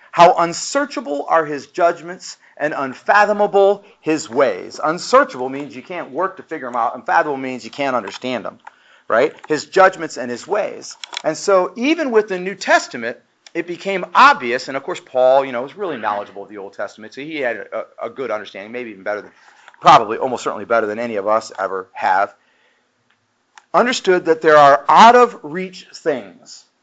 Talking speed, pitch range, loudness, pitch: 185 wpm, 130-190 Hz, -17 LUFS, 160 Hz